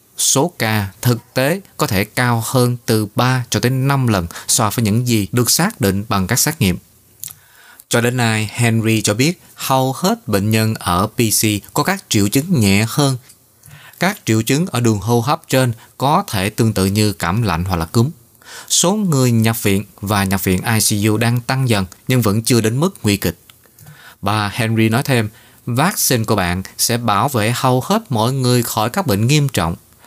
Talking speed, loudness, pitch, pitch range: 195 wpm, -16 LUFS, 115 Hz, 105-130 Hz